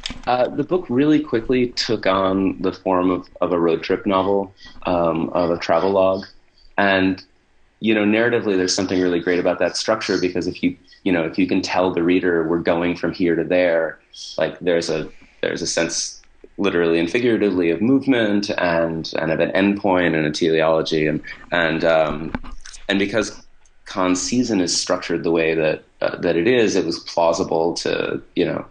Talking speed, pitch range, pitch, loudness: 185 wpm, 85-100 Hz, 90 Hz, -20 LUFS